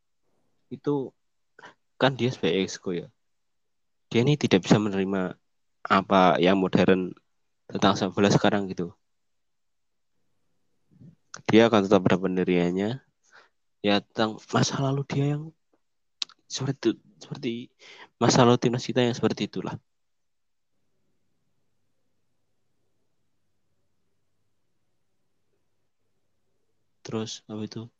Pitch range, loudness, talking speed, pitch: 95-125 Hz, -25 LUFS, 90 wpm, 110 Hz